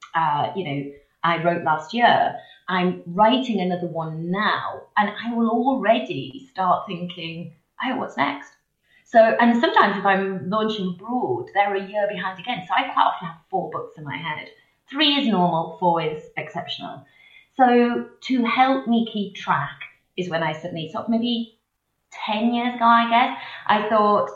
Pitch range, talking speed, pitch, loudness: 175-235 Hz, 170 wpm, 210 Hz, -22 LUFS